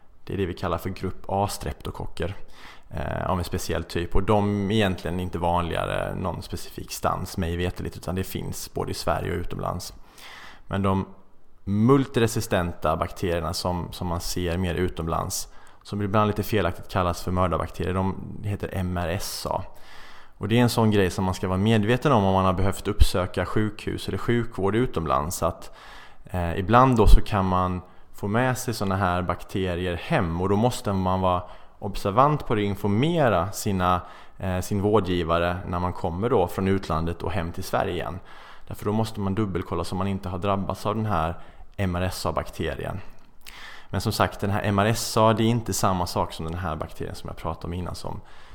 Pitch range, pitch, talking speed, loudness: 90-105 Hz, 95 Hz, 185 wpm, -25 LUFS